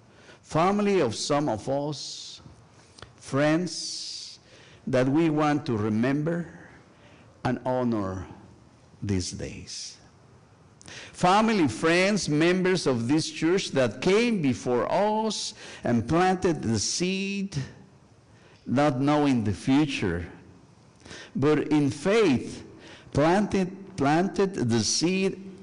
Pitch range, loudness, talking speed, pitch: 120-180 Hz, -25 LUFS, 95 wpm, 150 Hz